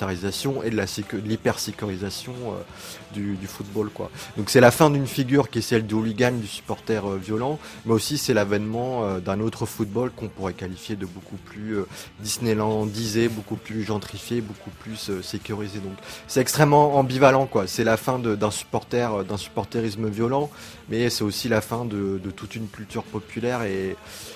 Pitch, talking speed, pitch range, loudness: 110 Hz, 190 wpm, 105-120 Hz, -24 LUFS